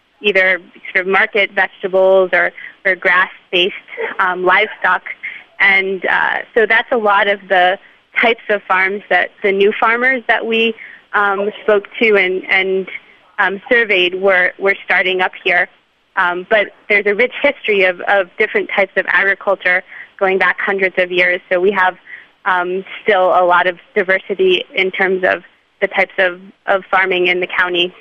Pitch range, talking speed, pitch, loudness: 185-205 Hz, 165 wpm, 195 Hz, -14 LUFS